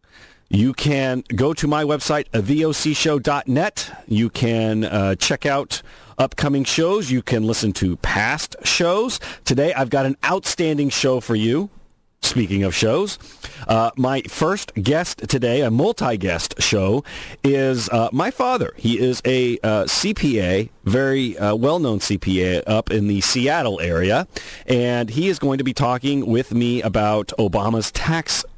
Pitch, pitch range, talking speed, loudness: 125 Hz, 110-145 Hz, 145 wpm, -19 LUFS